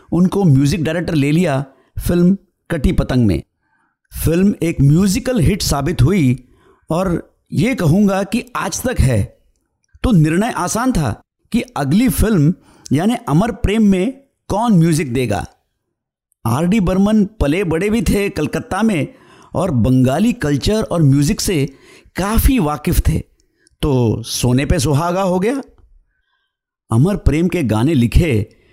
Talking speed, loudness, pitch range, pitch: 135 wpm, -16 LUFS, 135-200 Hz, 165 Hz